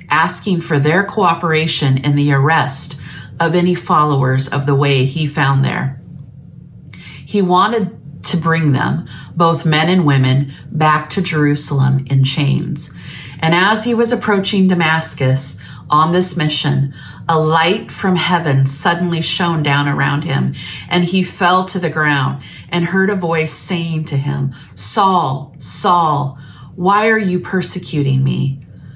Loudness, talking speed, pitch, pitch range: -15 LUFS, 140 wpm, 155 Hz, 140-175 Hz